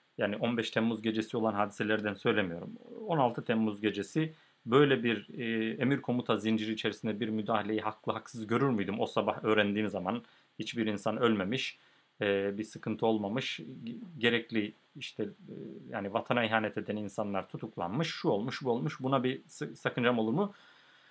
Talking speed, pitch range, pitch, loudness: 140 wpm, 110-125 Hz, 110 Hz, -32 LUFS